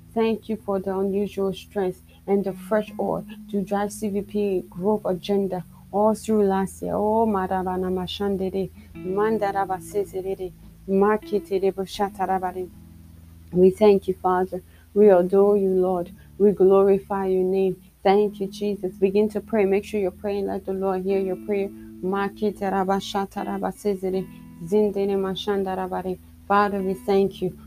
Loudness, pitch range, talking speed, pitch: -23 LUFS, 185-205 Hz, 115 wpm, 195 Hz